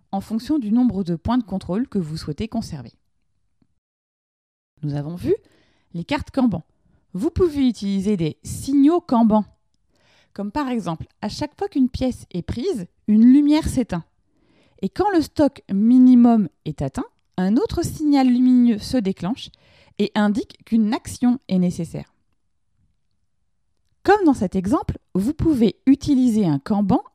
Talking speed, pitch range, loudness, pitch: 145 wpm, 180-265 Hz, -20 LUFS, 225 Hz